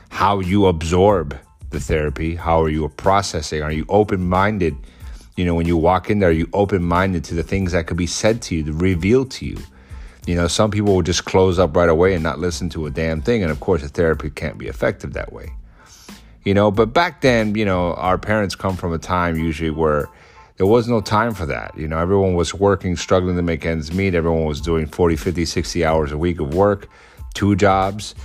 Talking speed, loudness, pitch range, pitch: 225 wpm, -19 LUFS, 80-100 Hz, 90 Hz